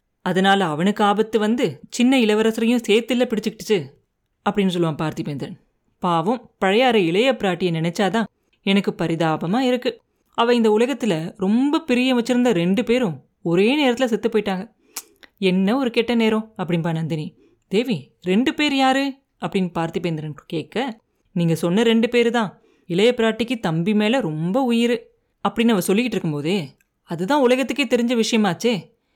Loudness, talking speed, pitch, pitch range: -20 LUFS, 130 wpm, 215 Hz, 180-240 Hz